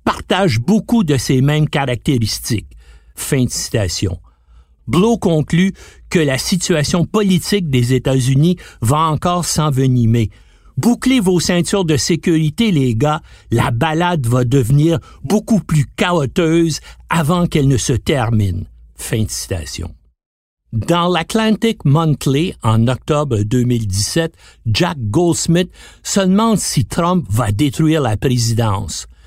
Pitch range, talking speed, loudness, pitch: 115-175 Hz, 120 wpm, -16 LUFS, 145 Hz